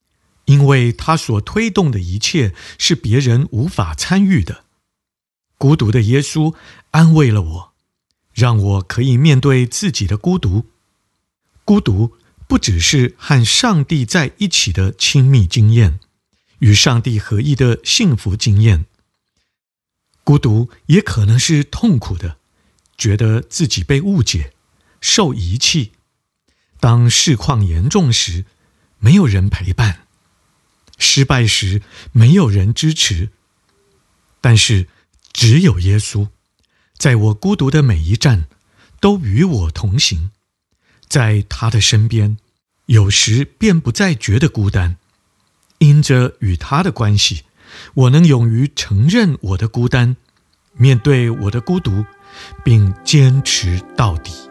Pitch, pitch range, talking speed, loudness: 115 Hz, 100-140 Hz, 180 characters per minute, -14 LUFS